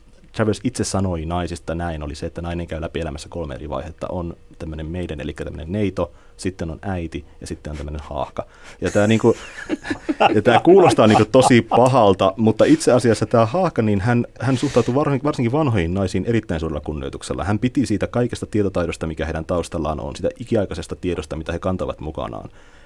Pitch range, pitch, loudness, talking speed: 80-115 Hz, 95 Hz, -20 LUFS, 180 wpm